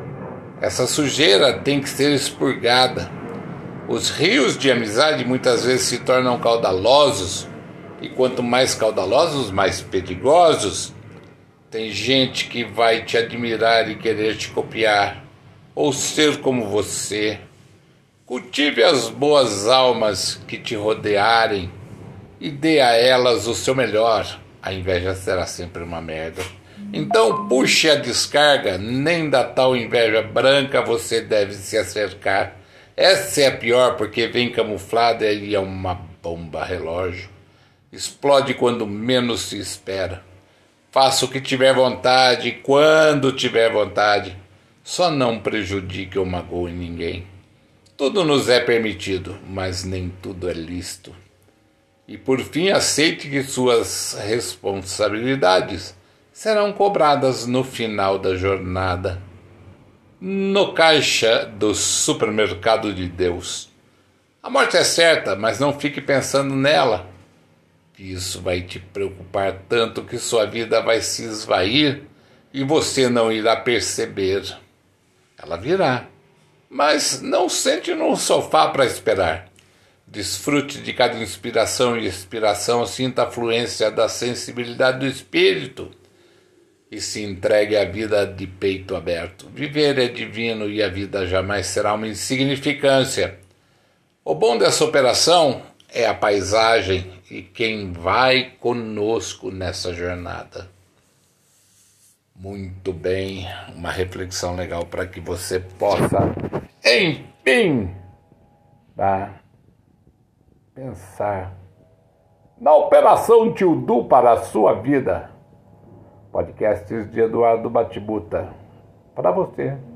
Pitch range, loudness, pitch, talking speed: 95-130 Hz, -19 LUFS, 110 Hz, 115 wpm